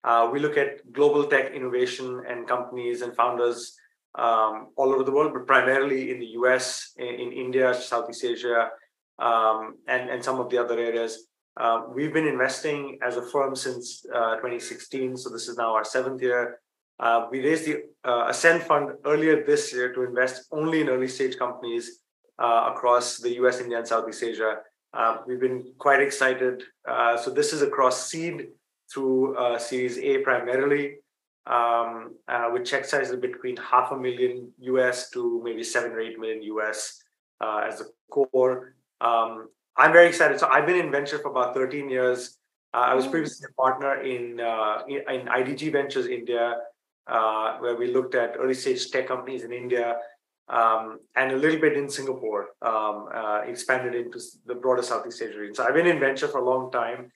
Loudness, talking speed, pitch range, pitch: -25 LUFS, 185 wpm, 120-140 Hz, 125 Hz